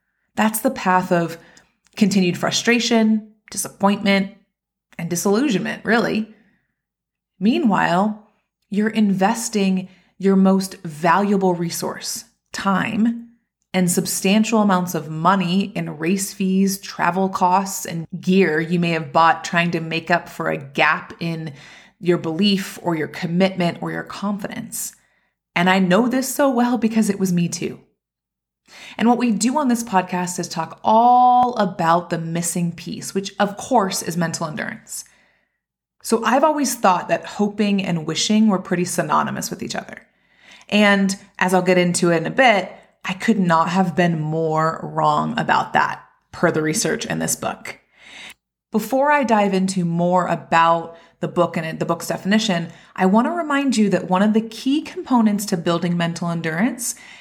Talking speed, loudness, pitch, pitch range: 155 wpm, -19 LUFS, 190 Hz, 170-215 Hz